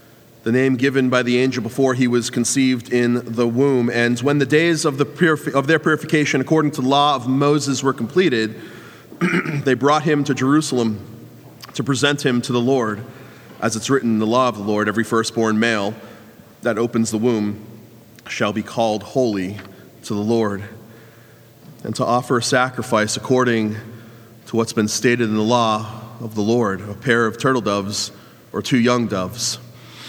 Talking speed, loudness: 180 wpm, -19 LUFS